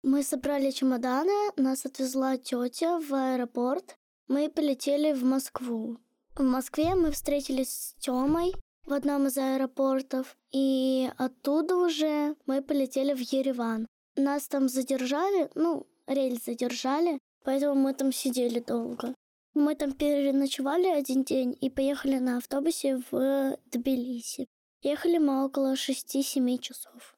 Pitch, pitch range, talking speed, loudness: 270 Hz, 260-290 Hz, 125 wpm, -29 LUFS